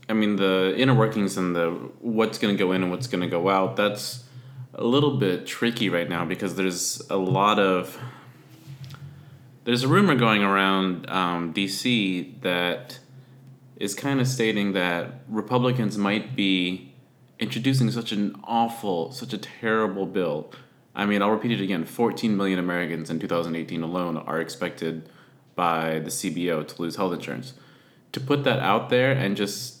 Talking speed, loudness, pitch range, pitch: 165 wpm, -24 LUFS, 90-125 Hz, 100 Hz